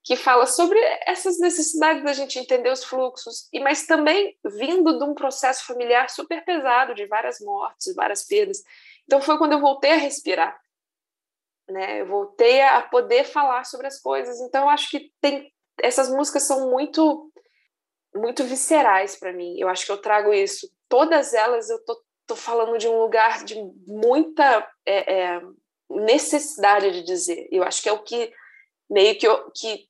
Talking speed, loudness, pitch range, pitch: 175 wpm, -21 LUFS, 230-345 Hz, 280 Hz